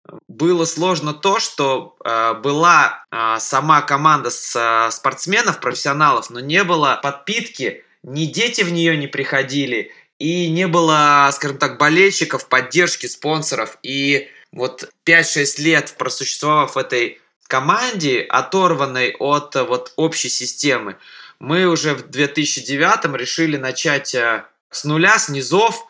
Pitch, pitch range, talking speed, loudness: 150 Hz, 135-165 Hz, 125 wpm, -17 LUFS